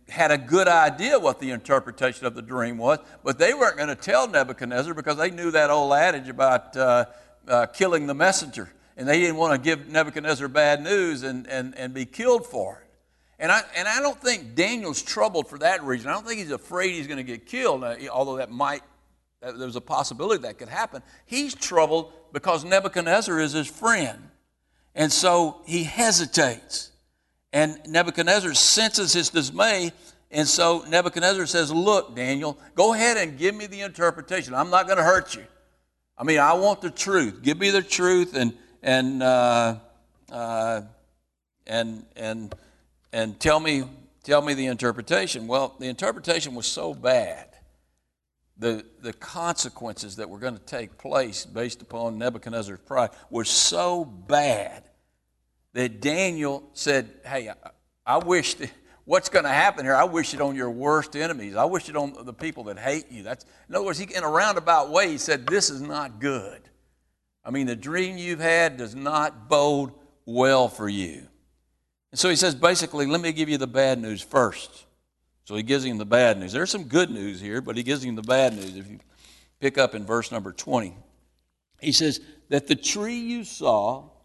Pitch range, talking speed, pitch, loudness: 115-170 Hz, 185 wpm, 140 Hz, -23 LUFS